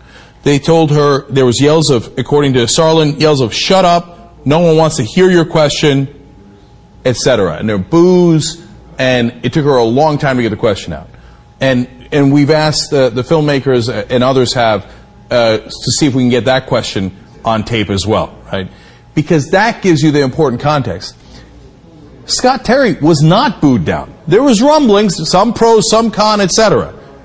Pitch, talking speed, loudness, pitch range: 145 Hz, 185 wpm, -11 LUFS, 125-165 Hz